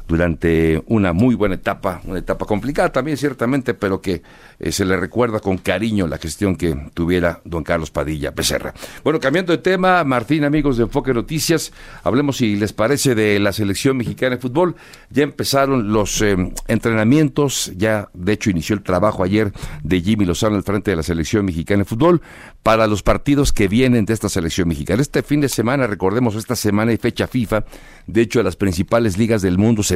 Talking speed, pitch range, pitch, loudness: 190 wpm, 95-125 Hz, 110 Hz, -18 LUFS